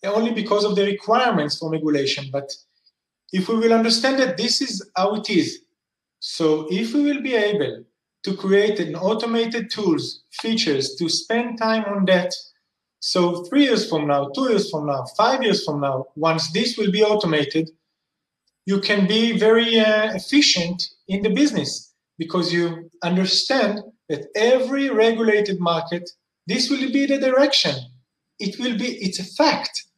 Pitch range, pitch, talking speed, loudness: 170-230 Hz, 205 Hz, 160 wpm, -20 LUFS